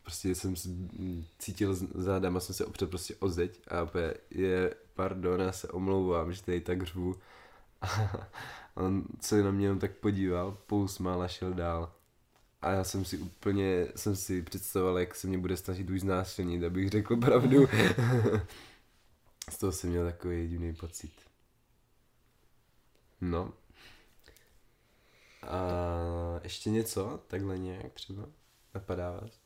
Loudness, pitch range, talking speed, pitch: -33 LUFS, 90-100 Hz, 140 wpm, 95 Hz